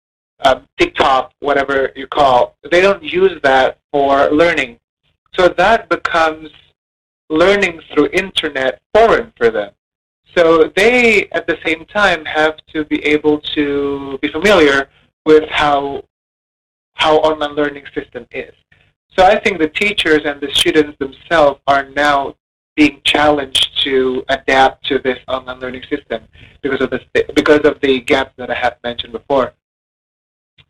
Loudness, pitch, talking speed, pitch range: -14 LUFS, 150 Hz, 135 wpm, 140-170 Hz